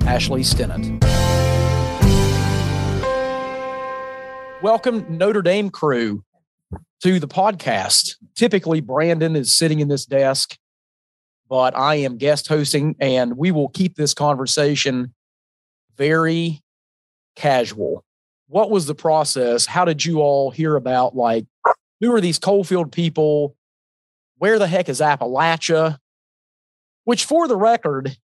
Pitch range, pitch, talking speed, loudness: 130-180 Hz, 150 Hz, 115 wpm, -18 LUFS